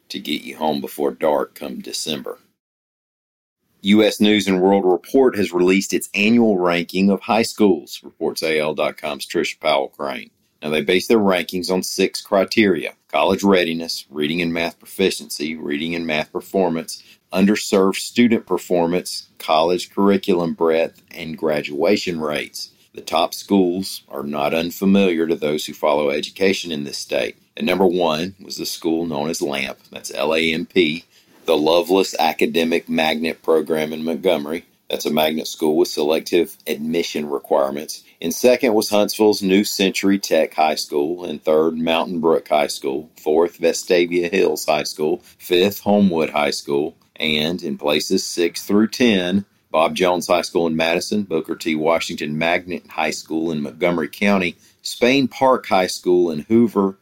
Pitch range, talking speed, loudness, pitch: 80-100 Hz, 155 wpm, -19 LUFS, 90 Hz